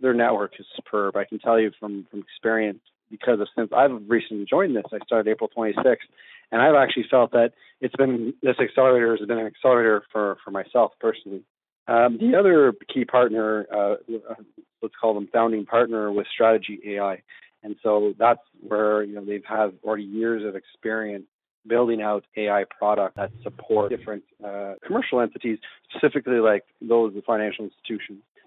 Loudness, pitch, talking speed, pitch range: -23 LUFS, 110 Hz, 175 wpm, 105-115 Hz